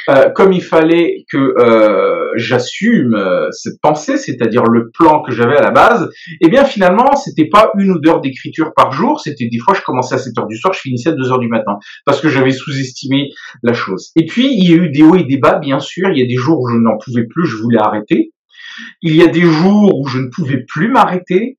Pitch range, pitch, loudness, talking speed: 130-195 Hz, 160 Hz, -12 LUFS, 250 wpm